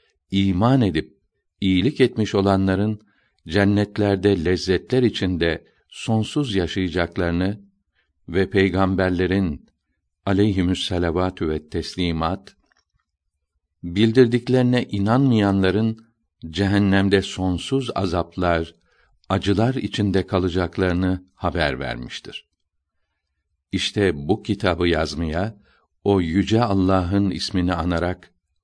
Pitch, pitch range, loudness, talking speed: 95 Hz, 85-100 Hz, -21 LUFS, 70 wpm